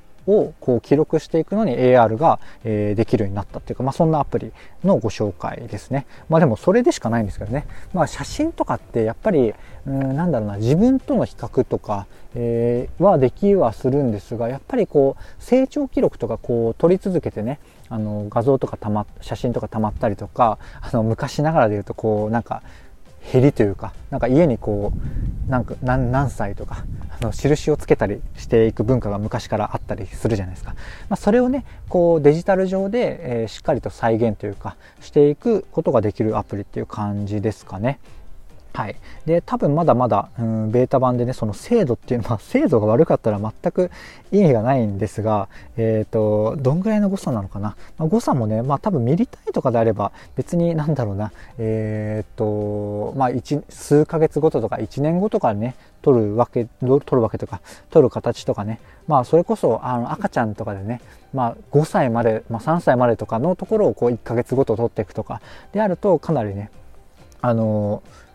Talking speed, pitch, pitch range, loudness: 370 characters per minute, 120 Hz, 105-150 Hz, -20 LUFS